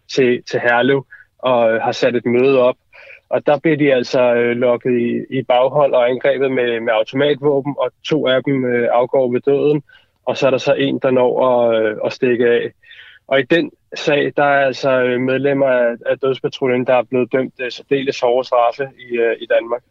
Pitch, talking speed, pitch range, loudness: 125 Hz, 170 wpm, 120-140 Hz, -16 LUFS